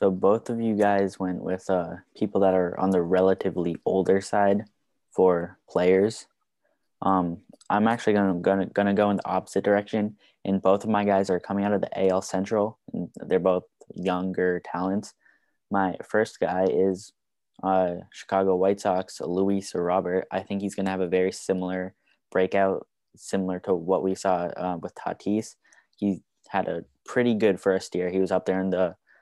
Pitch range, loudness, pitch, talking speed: 95-100 Hz, -25 LUFS, 95 Hz, 180 wpm